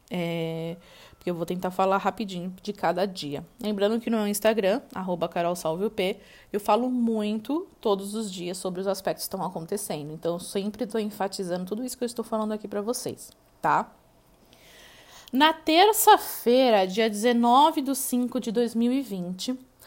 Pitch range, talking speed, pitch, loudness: 185-240 Hz, 155 wpm, 210 Hz, -26 LUFS